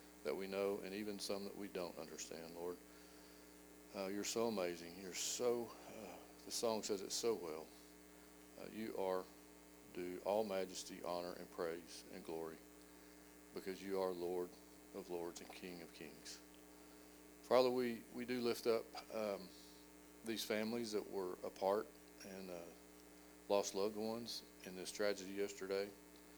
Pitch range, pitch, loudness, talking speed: 60-100 Hz, 85 Hz, -44 LUFS, 150 wpm